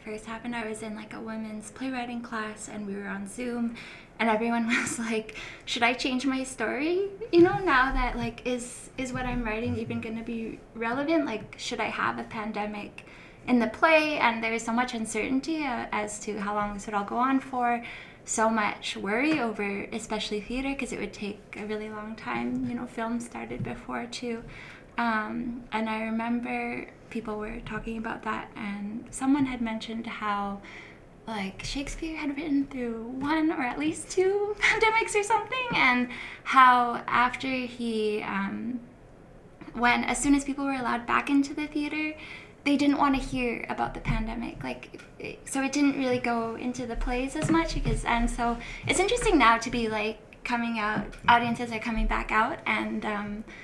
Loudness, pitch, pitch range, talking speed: -28 LUFS, 235 Hz, 220-265 Hz, 185 wpm